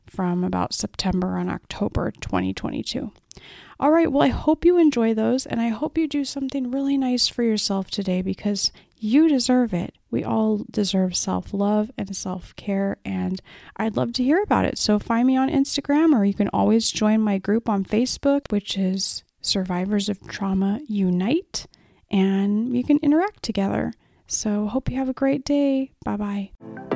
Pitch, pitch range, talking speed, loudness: 215 Hz, 195-270 Hz, 175 wpm, -22 LUFS